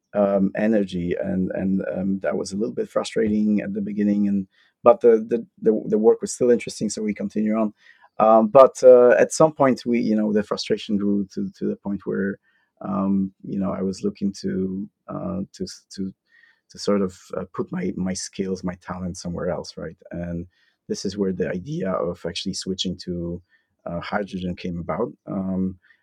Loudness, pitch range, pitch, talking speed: -22 LUFS, 95-120 Hz, 100 Hz, 190 wpm